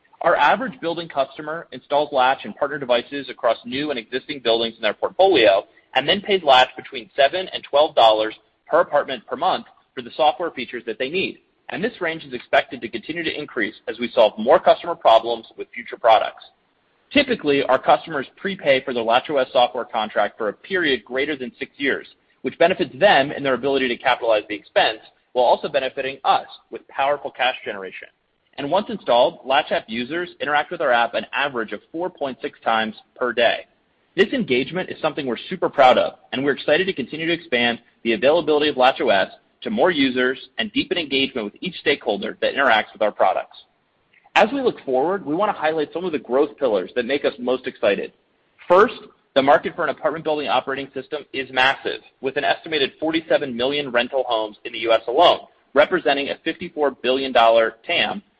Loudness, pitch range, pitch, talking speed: -20 LUFS, 125-160 Hz, 140 Hz, 190 wpm